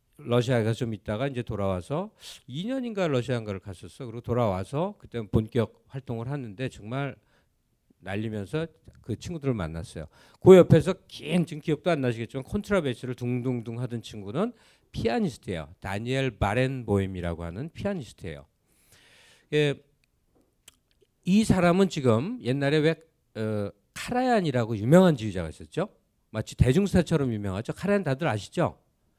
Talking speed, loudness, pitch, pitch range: 335 characters per minute, -27 LUFS, 125 Hz, 110-160 Hz